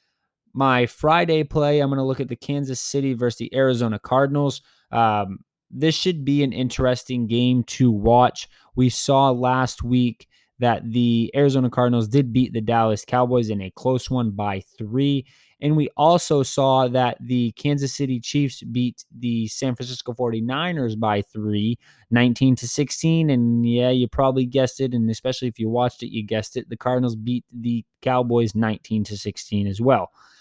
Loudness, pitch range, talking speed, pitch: -21 LUFS, 115-135 Hz, 170 wpm, 125 Hz